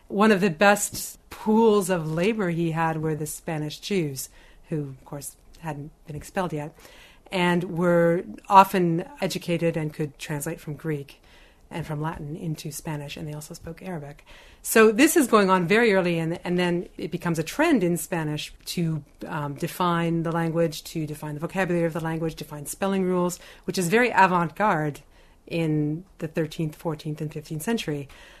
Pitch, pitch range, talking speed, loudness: 170 Hz, 155-185 Hz, 170 wpm, -24 LUFS